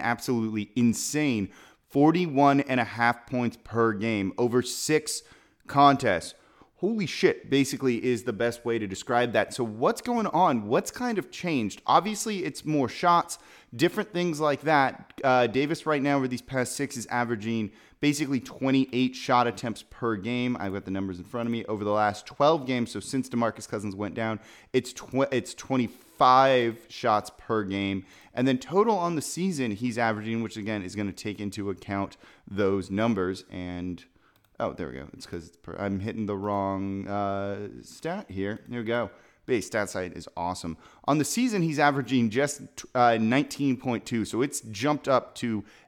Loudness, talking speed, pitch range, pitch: -27 LUFS, 175 wpm, 105-140 Hz, 120 Hz